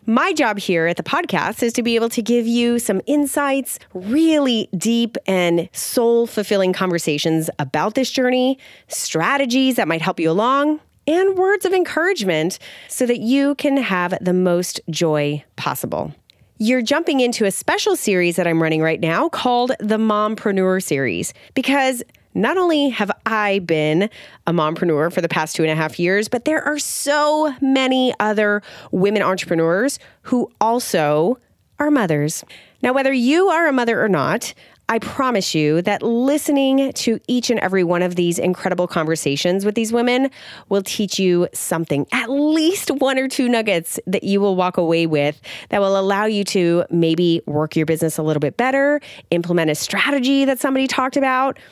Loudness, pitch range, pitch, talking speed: -18 LUFS, 175-265 Hz, 210 Hz, 170 wpm